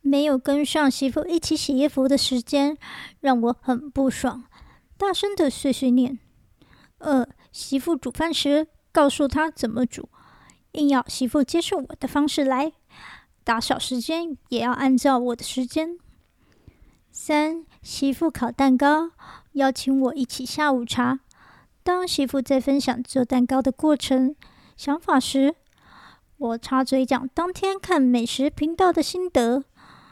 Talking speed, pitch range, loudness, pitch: 205 characters per minute, 260-305 Hz, -23 LUFS, 275 Hz